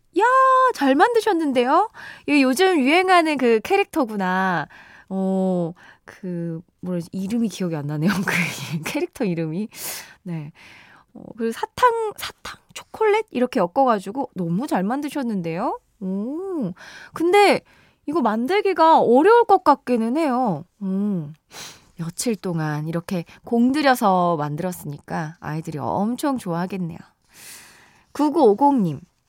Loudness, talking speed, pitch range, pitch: -20 LUFS, 255 characters per minute, 175-300 Hz, 220 Hz